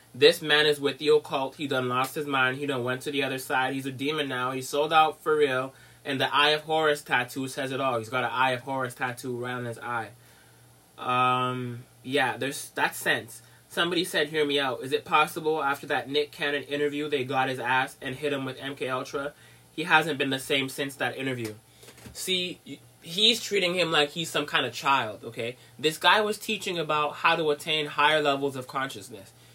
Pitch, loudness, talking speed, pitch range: 145 Hz, -26 LUFS, 215 wpm, 130-155 Hz